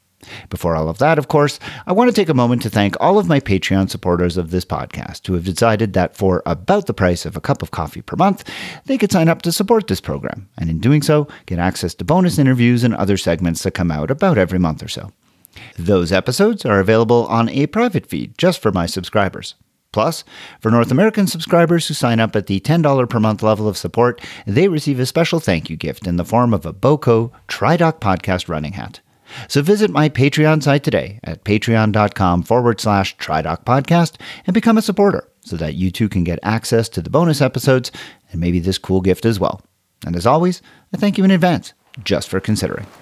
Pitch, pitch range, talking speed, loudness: 115 Hz, 95-150 Hz, 215 wpm, -16 LUFS